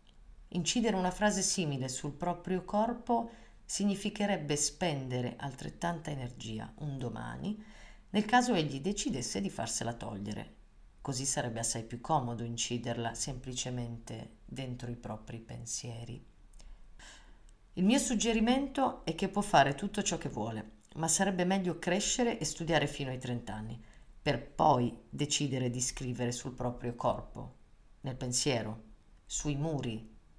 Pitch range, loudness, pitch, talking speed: 115-180 Hz, -33 LUFS, 135 Hz, 125 wpm